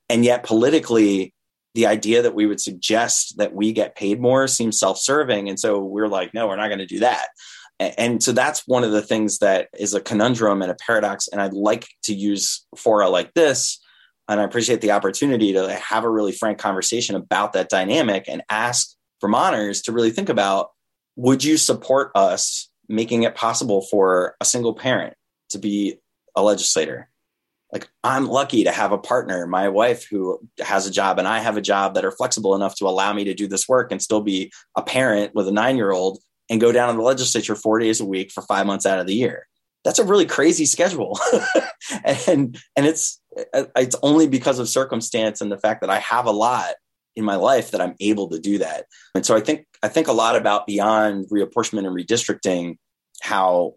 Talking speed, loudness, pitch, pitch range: 205 wpm, -20 LUFS, 110 Hz, 100-120 Hz